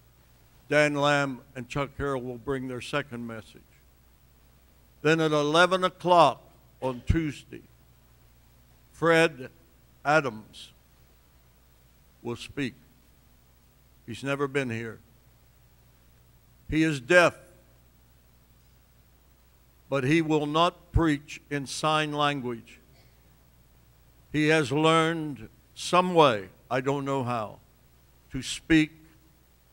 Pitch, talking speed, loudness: 120 Hz, 95 wpm, -26 LUFS